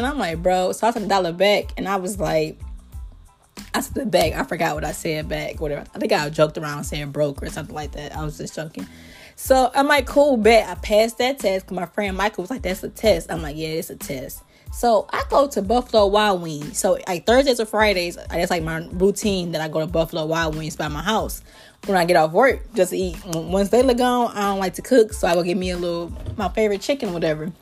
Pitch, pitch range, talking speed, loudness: 190 Hz, 165-220 Hz, 255 wpm, -21 LUFS